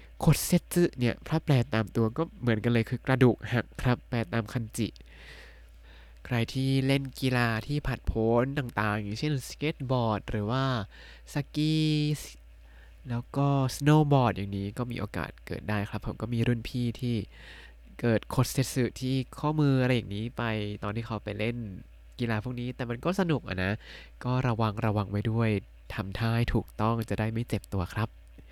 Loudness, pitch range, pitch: -29 LUFS, 105-130 Hz, 115 Hz